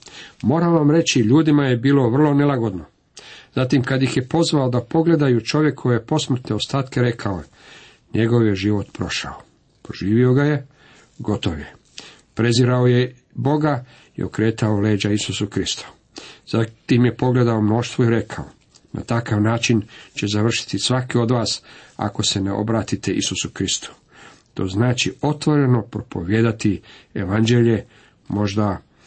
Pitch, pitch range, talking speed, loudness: 120 Hz, 105-130 Hz, 135 wpm, -19 LUFS